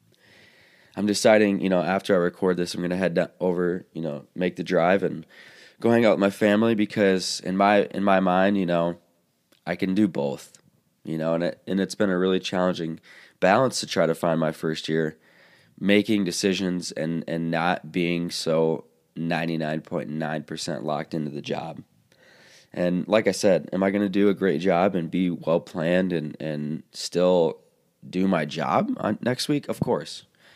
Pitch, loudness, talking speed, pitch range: 90 Hz, -24 LUFS, 190 wpm, 80-95 Hz